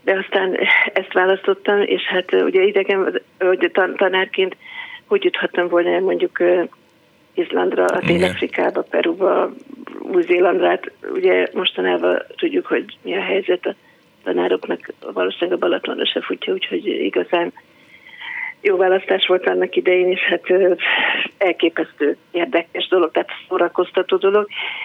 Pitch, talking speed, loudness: 195 Hz, 125 wpm, -18 LUFS